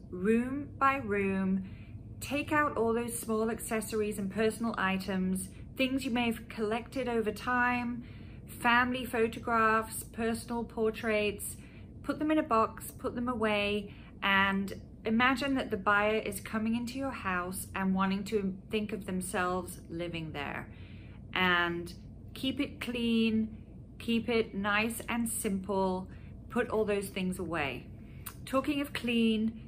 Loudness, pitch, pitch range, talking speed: -32 LUFS, 220 Hz, 195-240 Hz, 135 wpm